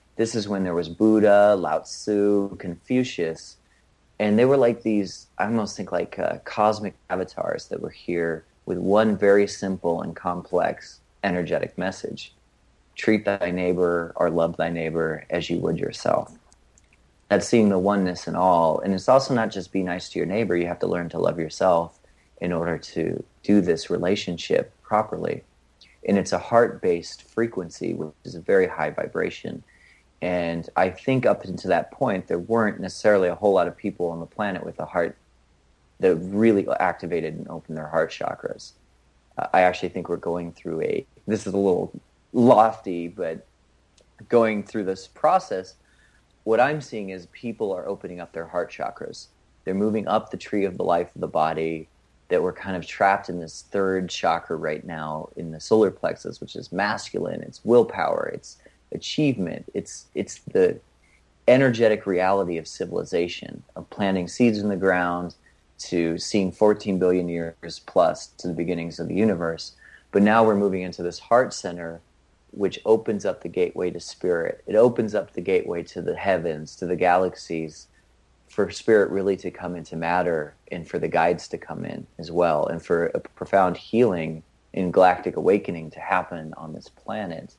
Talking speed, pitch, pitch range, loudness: 175 wpm, 90 Hz, 85-105 Hz, -24 LUFS